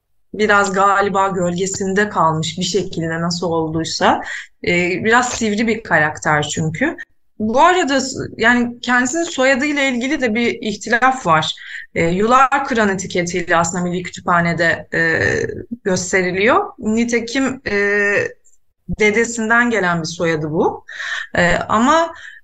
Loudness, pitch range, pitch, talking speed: -16 LUFS, 180-250 Hz, 210 Hz, 110 wpm